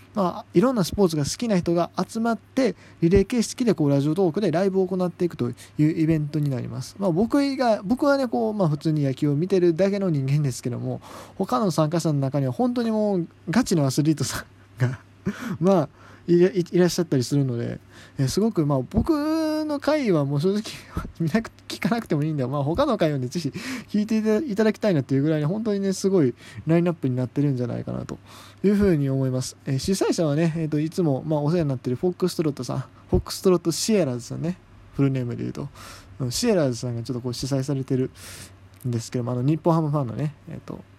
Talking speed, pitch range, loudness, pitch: 460 characters per minute, 130-195 Hz, -24 LUFS, 160 Hz